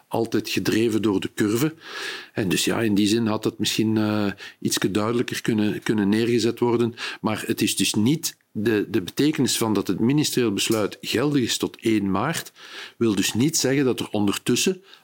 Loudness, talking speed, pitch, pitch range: -23 LUFS, 185 wpm, 115 Hz, 105-125 Hz